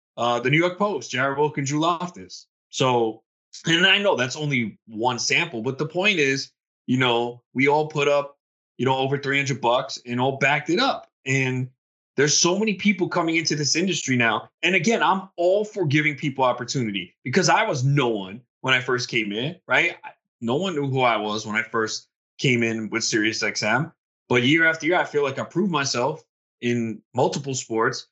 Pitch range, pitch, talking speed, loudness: 120-160 Hz, 135 Hz, 200 wpm, -22 LUFS